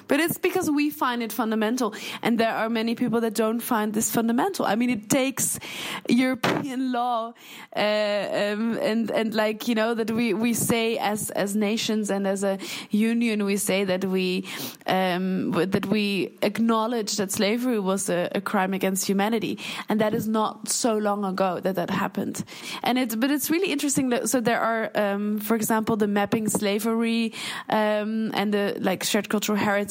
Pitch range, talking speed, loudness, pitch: 205-235 Hz, 180 wpm, -24 LUFS, 220 Hz